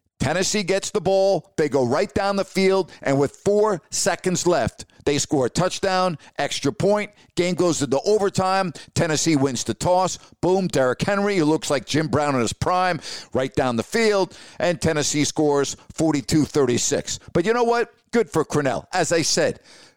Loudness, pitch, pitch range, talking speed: -21 LUFS, 170 Hz, 145-195 Hz, 180 wpm